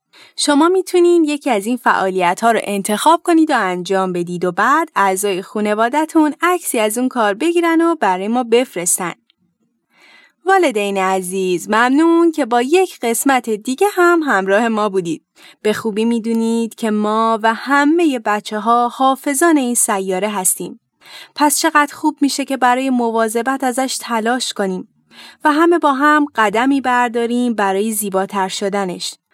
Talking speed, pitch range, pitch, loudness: 145 wpm, 210-300 Hz, 240 Hz, -15 LUFS